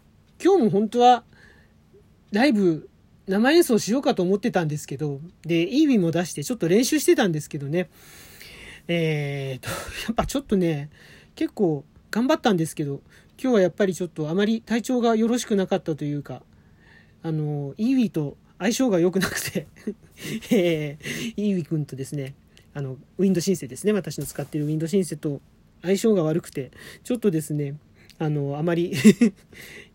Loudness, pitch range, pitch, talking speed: -23 LUFS, 155-225 Hz, 180 Hz, 350 characters per minute